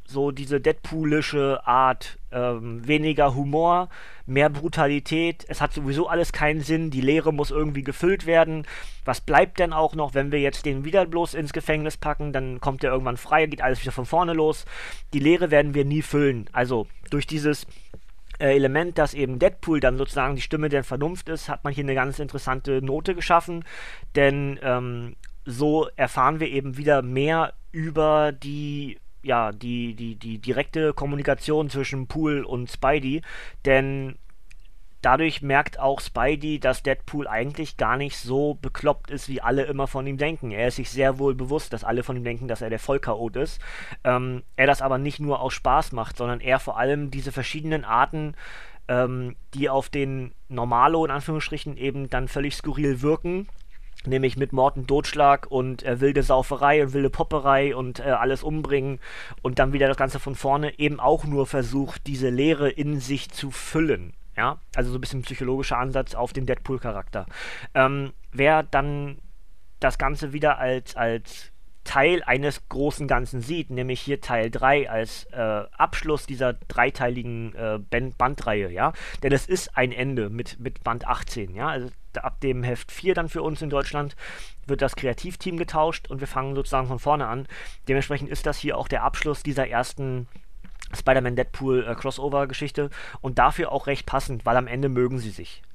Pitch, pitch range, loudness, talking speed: 140 Hz, 130-150 Hz, -24 LUFS, 175 wpm